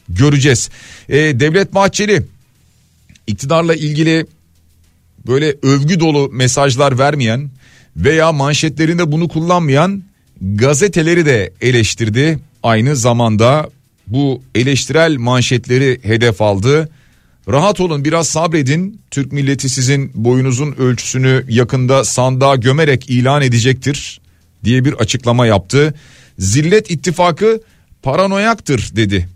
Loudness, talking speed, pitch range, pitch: -13 LUFS, 95 wpm, 120-155 Hz, 135 Hz